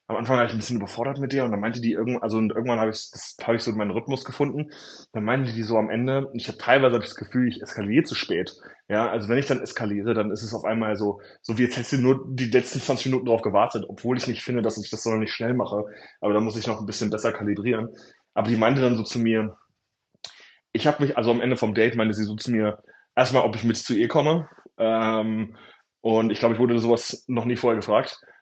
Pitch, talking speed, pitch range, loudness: 115 Hz, 260 wpm, 110-125 Hz, -24 LUFS